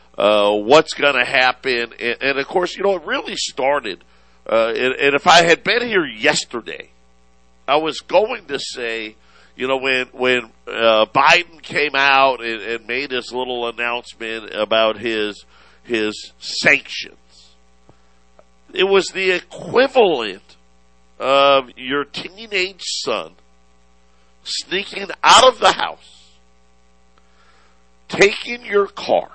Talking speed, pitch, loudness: 125 wpm, 115 Hz, -17 LUFS